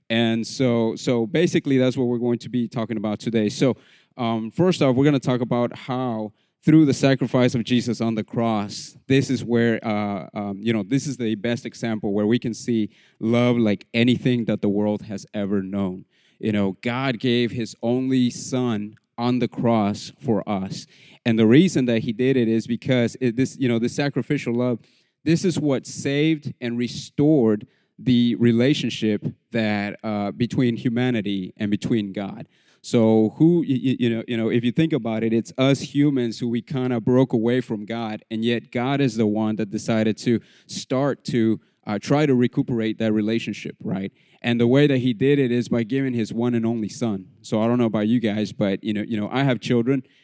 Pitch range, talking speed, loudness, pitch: 110-130 Hz, 205 wpm, -22 LUFS, 120 Hz